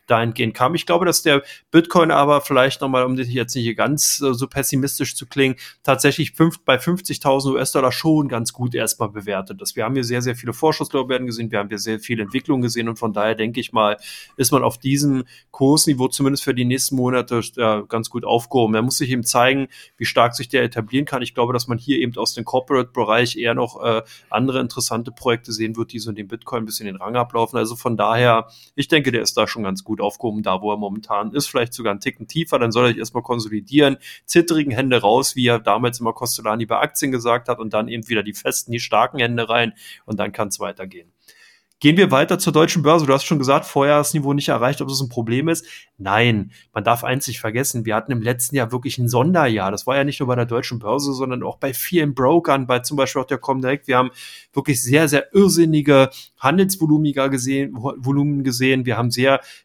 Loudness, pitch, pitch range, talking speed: -19 LUFS, 125 Hz, 115-140 Hz, 225 wpm